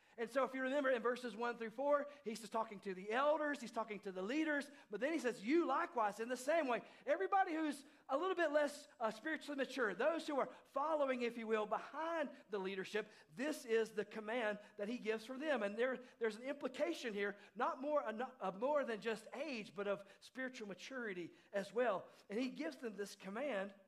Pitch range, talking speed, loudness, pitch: 215-290 Hz, 210 wpm, -41 LUFS, 245 Hz